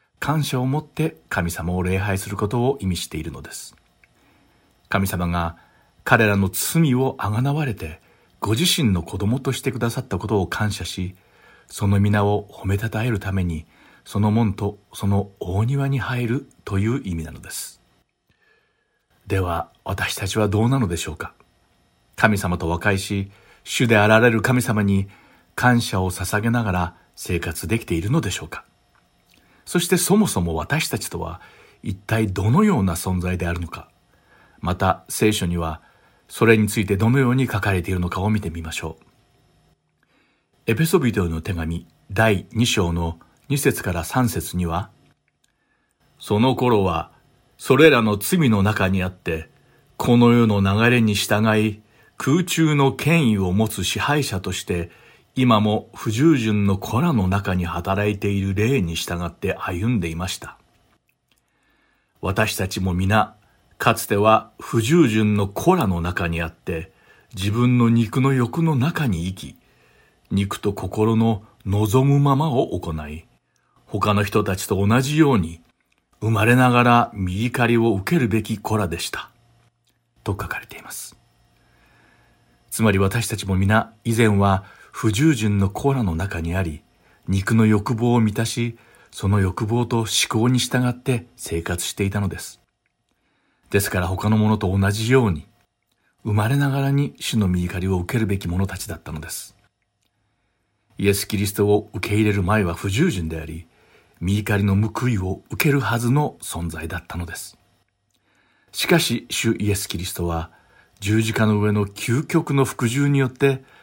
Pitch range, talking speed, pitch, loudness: 95-120 Hz, 280 characters per minute, 105 Hz, -21 LUFS